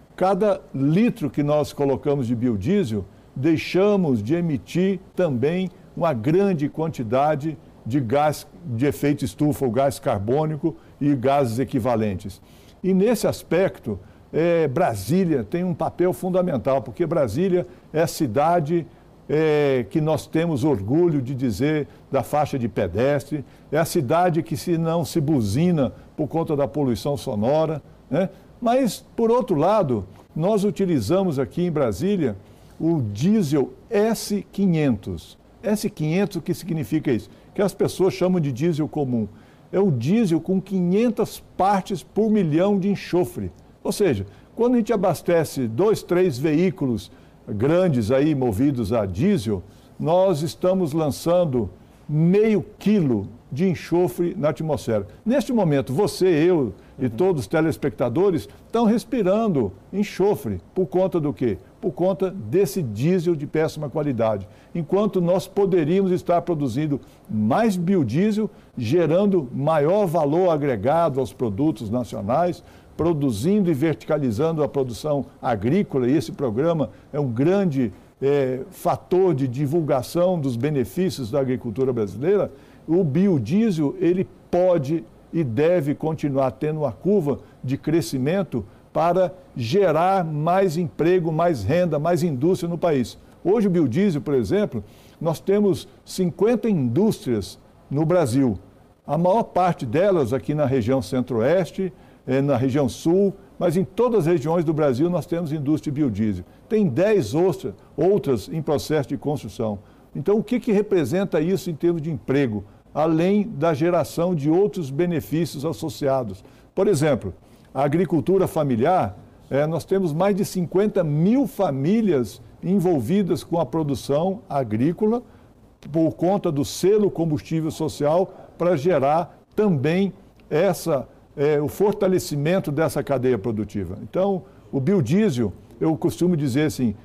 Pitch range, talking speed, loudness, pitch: 135-185 Hz, 130 wpm, -22 LUFS, 160 Hz